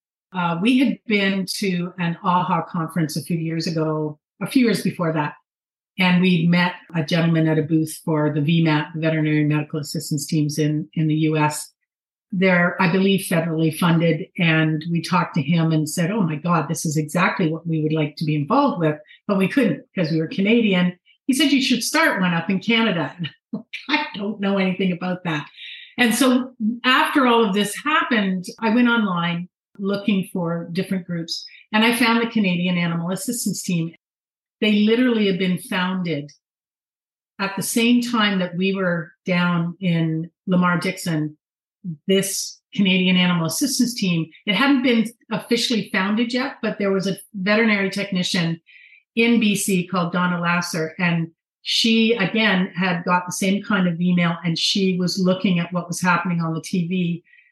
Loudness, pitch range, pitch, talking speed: -20 LUFS, 165-210 Hz, 180 Hz, 175 wpm